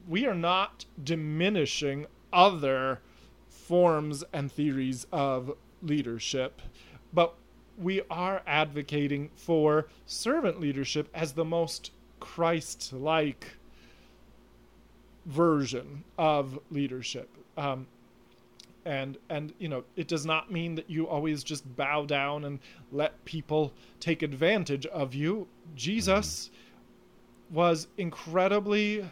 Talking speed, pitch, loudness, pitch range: 100 wpm, 150 Hz, -30 LUFS, 135-170 Hz